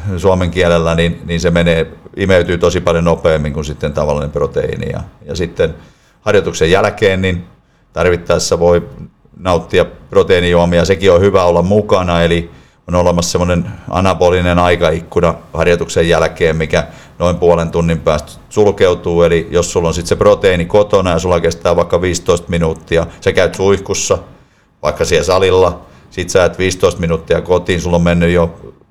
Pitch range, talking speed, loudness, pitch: 85-95 Hz, 150 wpm, -13 LUFS, 85 Hz